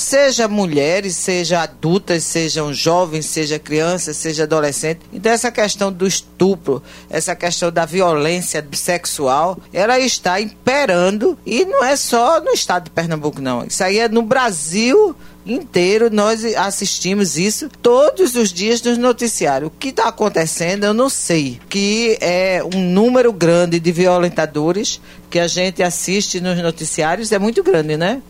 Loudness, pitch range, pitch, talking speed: -16 LUFS, 170-225 Hz, 185 Hz, 150 wpm